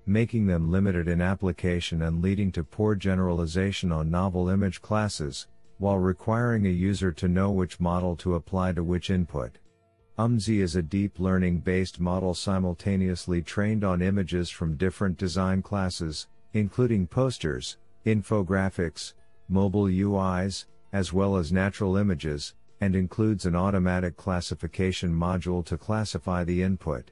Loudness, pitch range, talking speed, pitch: -27 LUFS, 90-100 Hz, 135 wpm, 95 Hz